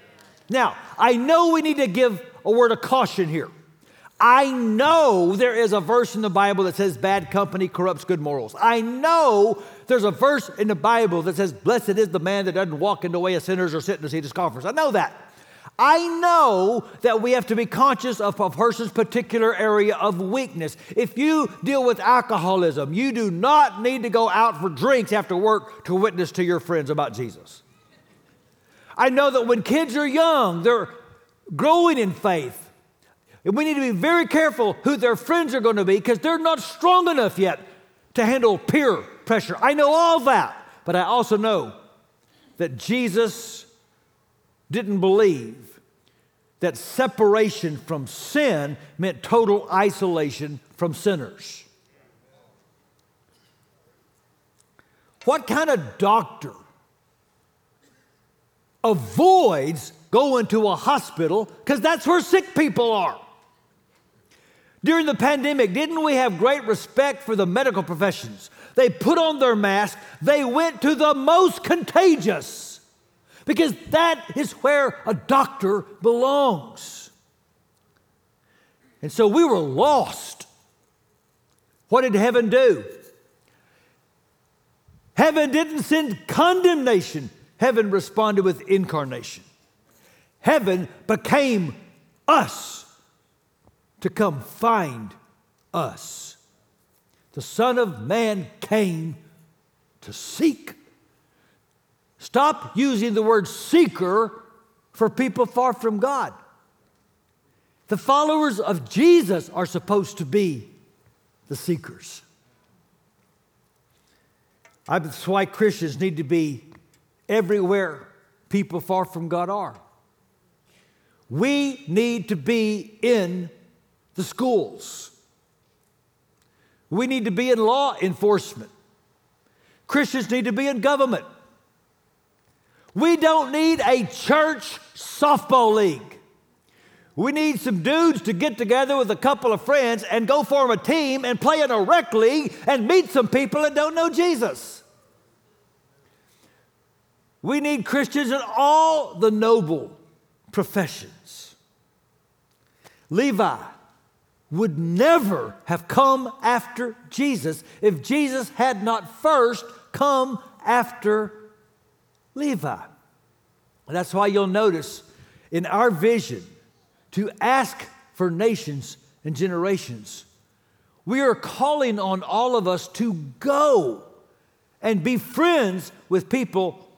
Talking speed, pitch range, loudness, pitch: 125 wpm, 185-270 Hz, -21 LUFS, 225 Hz